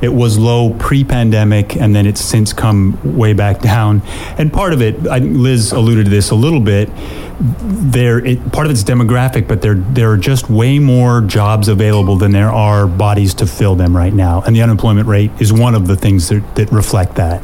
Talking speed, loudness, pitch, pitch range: 205 wpm, -11 LUFS, 110 Hz, 100-120 Hz